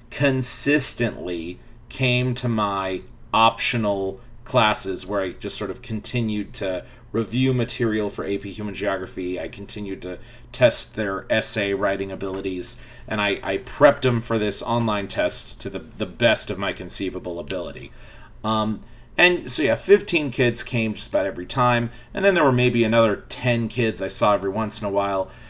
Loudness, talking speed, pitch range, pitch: -23 LUFS, 165 wpm, 100-120 Hz, 110 Hz